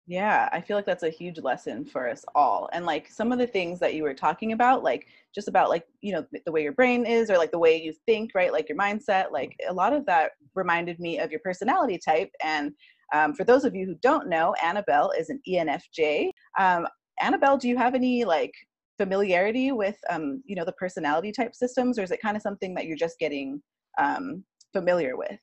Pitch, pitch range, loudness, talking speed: 200 Hz, 170-250 Hz, -26 LUFS, 225 wpm